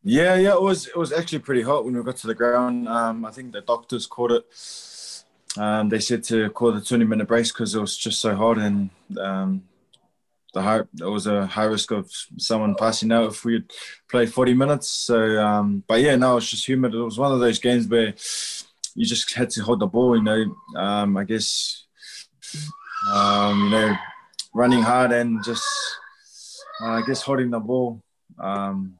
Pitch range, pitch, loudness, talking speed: 110-125 Hz, 115 Hz, -22 LUFS, 200 wpm